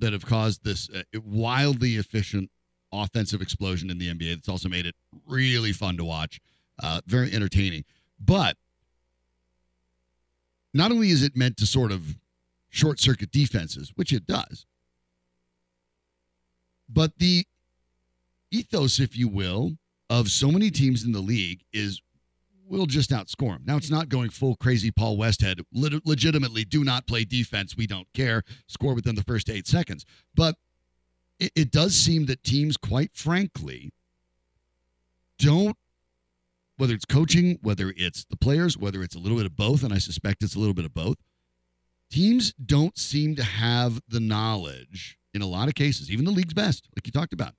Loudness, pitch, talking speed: -25 LUFS, 105 Hz, 165 wpm